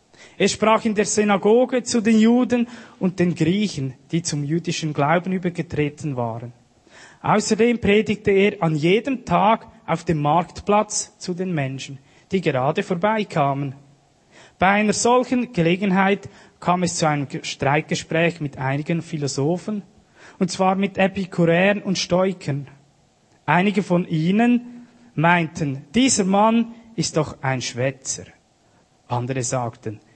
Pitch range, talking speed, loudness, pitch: 145-210 Hz, 125 wpm, -21 LUFS, 175 Hz